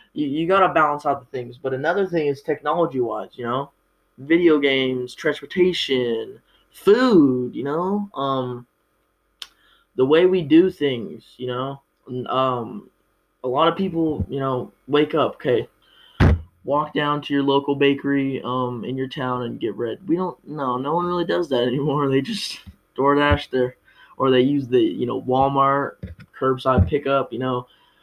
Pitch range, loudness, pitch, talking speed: 125-155 Hz, -21 LUFS, 140 Hz, 165 wpm